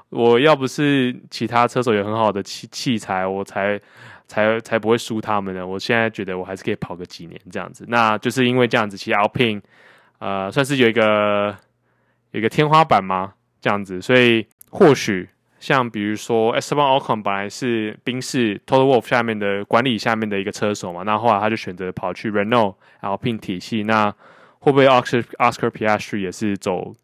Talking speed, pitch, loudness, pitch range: 365 characters per minute, 110 Hz, -19 LUFS, 100-120 Hz